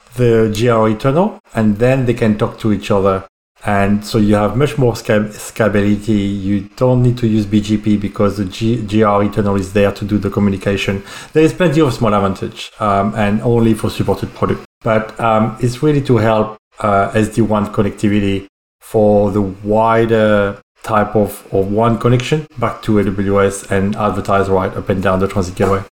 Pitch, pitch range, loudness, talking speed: 105 Hz, 100-115 Hz, -15 LUFS, 180 wpm